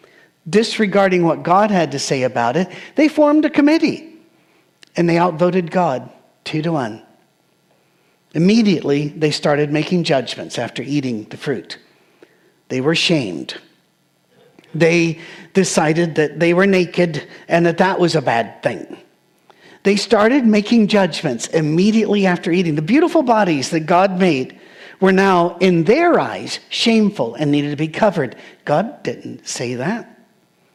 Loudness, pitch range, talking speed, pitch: -16 LUFS, 155-200 Hz, 140 wpm, 175 Hz